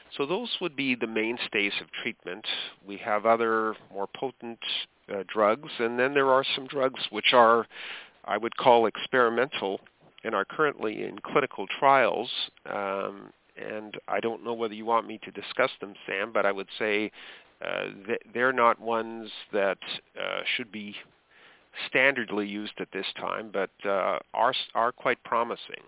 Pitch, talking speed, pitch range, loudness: 115 Hz, 160 wpm, 105-125 Hz, -27 LUFS